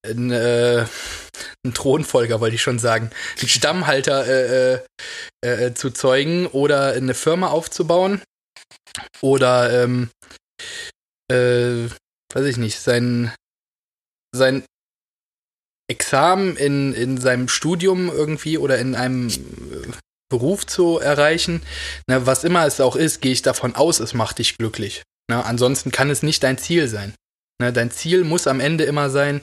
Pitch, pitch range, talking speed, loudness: 130 Hz, 120-150 Hz, 135 wpm, -19 LUFS